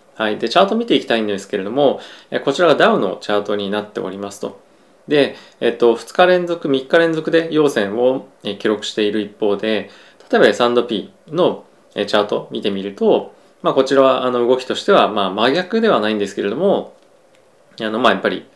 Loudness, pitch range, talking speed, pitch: -17 LUFS, 105-150 Hz, 365 characters per minute, 120 Hz